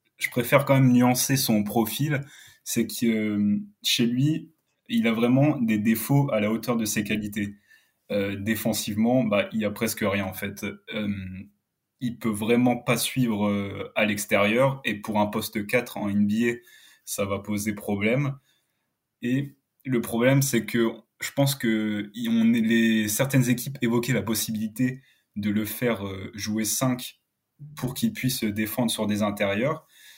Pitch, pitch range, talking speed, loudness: 115 Hz, 105-125 Hz, 145 wpm, -25 LUFS